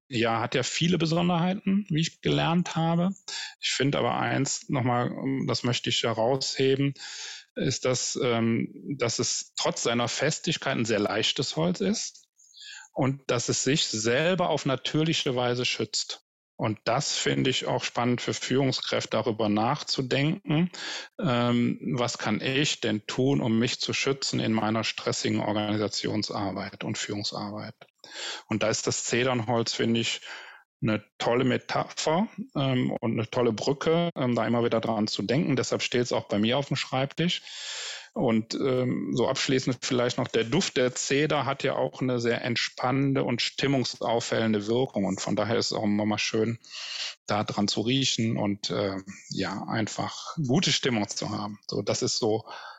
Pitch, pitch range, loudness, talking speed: 125 Hz, 115-140 Hz, -27 LUFS, 160 wpm